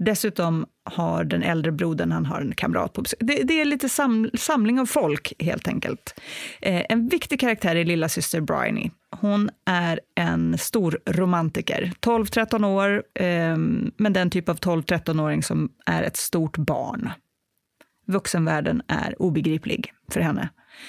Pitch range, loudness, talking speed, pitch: 165-225 Hz, -24 LUFS, 145 wpm, 185 Hz